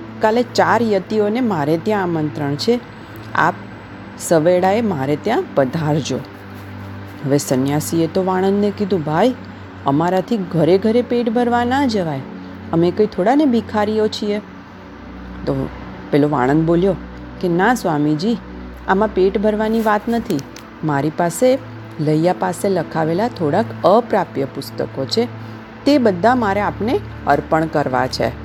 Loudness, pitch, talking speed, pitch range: -18 LUFS, 175 Hz, 115 wpm, 140-215 Hz